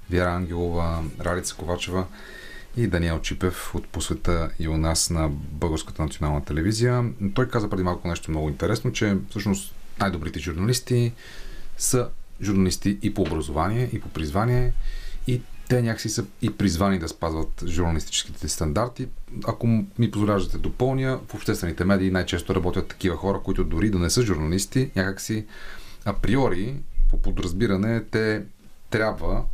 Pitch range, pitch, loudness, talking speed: 85-110 Hz, 95 Hz, -25 LUFS, 140 wpm